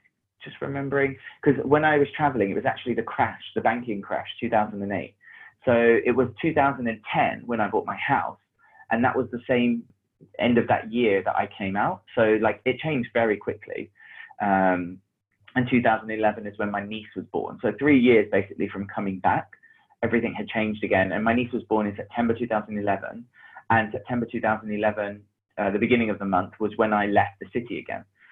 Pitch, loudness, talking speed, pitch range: 110 Hz, -24 LUFS, 185 wpm, 105-125 Hz